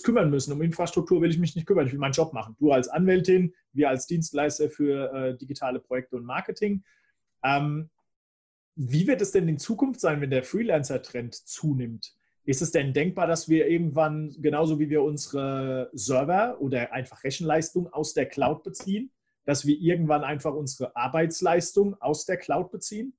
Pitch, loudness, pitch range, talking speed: 155 Hz, -26 LUFS, 135-175 Hz, 175 wpm